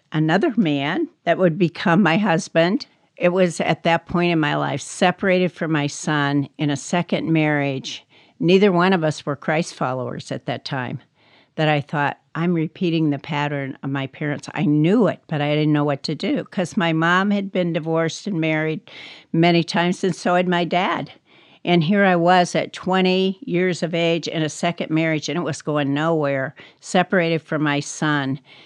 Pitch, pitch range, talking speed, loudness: 165 Hz, 150-180 Hz, 190 wpm, -20 LUFS